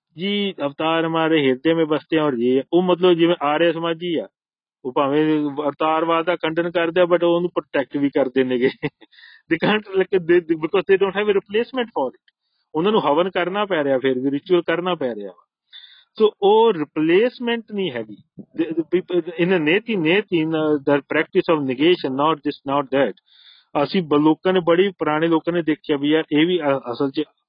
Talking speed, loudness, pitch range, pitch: 185 wpm, -20 LUFS, 150-190 Hz, 170 Hz